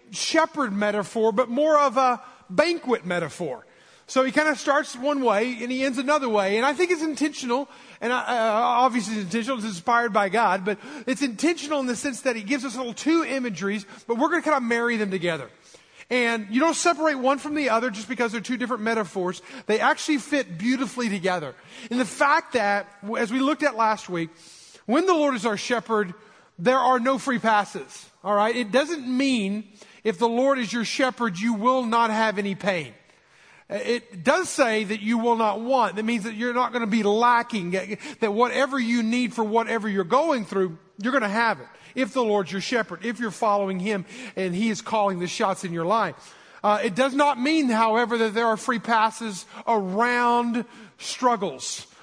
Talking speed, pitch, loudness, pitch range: 210 wpm, 235 Hz, -24 LUFS, 210-260 Hz